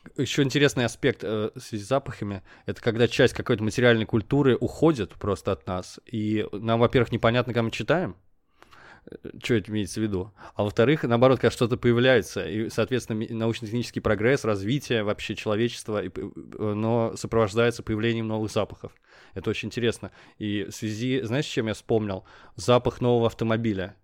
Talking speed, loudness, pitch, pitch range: 150 wpm, -25 LUFS, 115 Hz, 110-120 Hz